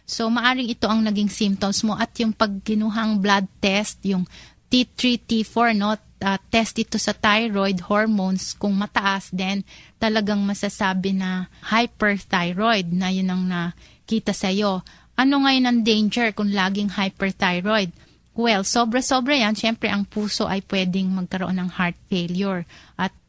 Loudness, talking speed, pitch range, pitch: -21 LUFS, 140 wpm, 190-225 Hz, 205 Hz